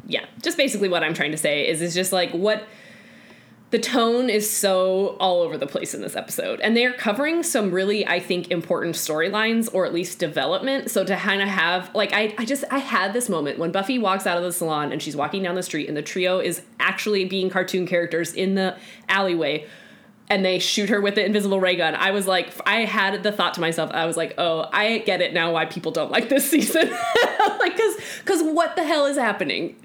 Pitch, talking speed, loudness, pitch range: 195 Hz, 230 wpm, -22 LUFS, 175-230 Hz